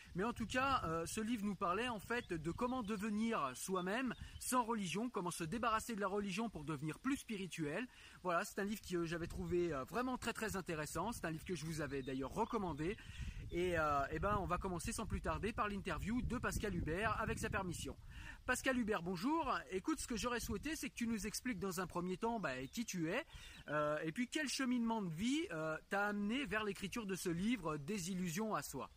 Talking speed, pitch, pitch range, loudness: 205 wpm, 200 Hz, 170-235 Hz, -41 LUFS